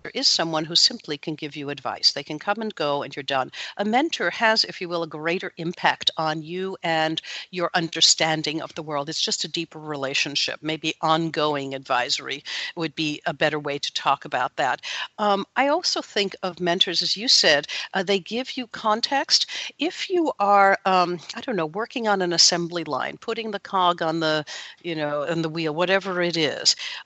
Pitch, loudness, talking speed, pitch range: 170 Hz, -23 LUFS, 200 wpm, 155-205 Hz